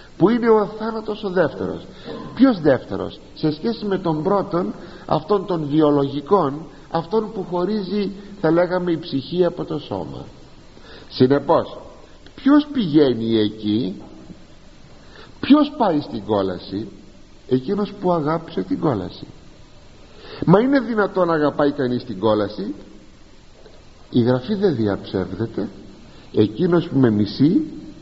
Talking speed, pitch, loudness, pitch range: 120 wpm, 165 Hz, -20 LUFS, 130-205 Hz